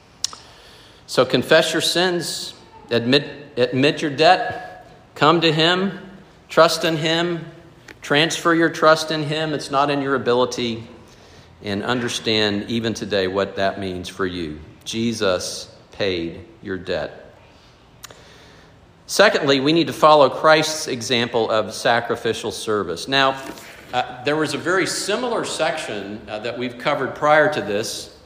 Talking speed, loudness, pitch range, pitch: 130 wpm, -19 LUFS, 115-160 Hz, 140 Hz